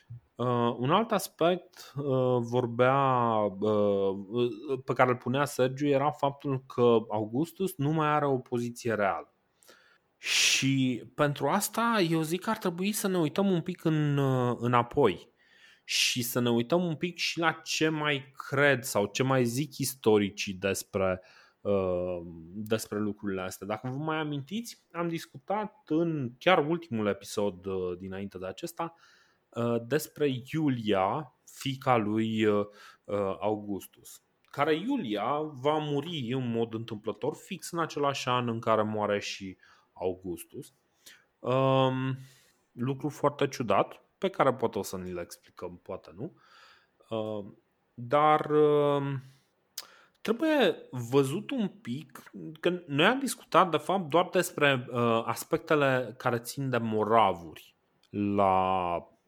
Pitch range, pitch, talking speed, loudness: 110-155 Hz, 130 Hz, 125 wpm, -29 LUFS